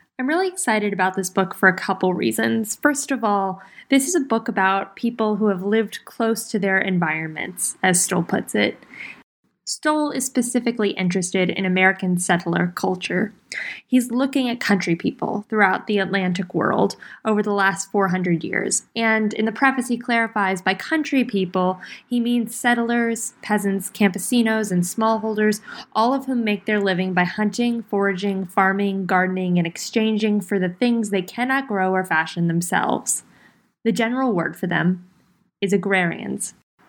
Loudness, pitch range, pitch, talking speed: -21 LUFS, 185-230 Hz, 200 Hz, 160 wpm